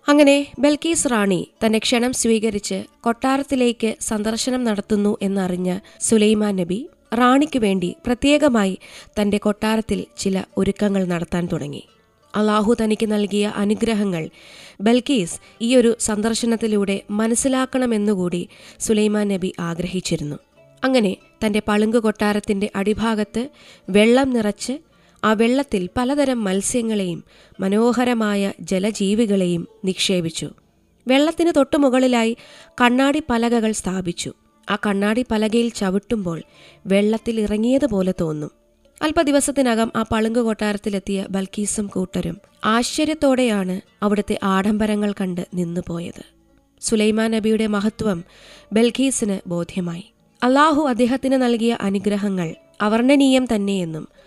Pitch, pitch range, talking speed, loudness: 215 Hz, 195-240 Hz, 90 wpm, -20 LUFS